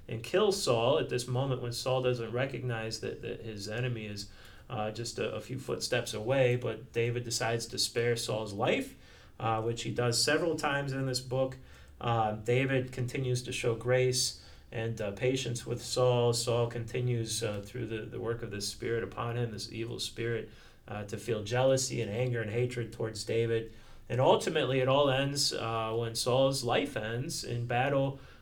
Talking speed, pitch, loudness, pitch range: 180 wpm, 120 Hz, -32 LUFS, 110-125 Hz